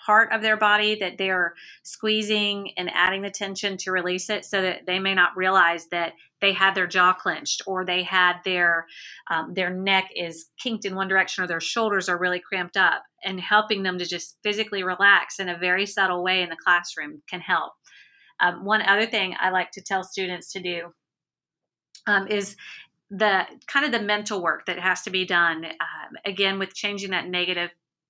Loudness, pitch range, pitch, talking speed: -23 LUFS, 180-200 Hz, 185 Hz, 195 wpm